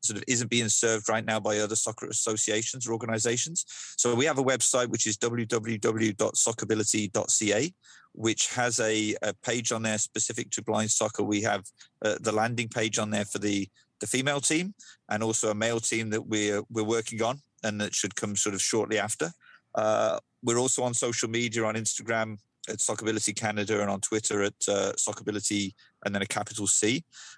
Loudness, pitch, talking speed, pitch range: -27 LUFS, 110 Hz, 185 wpm, 105-120 Hz